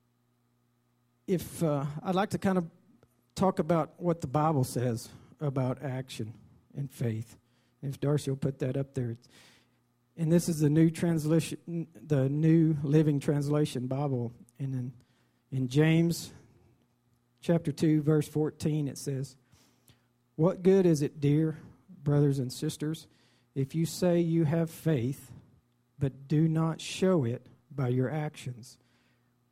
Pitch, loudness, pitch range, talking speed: 140 Hz, -30 LUFS, 125-160 Hz, 135 wpm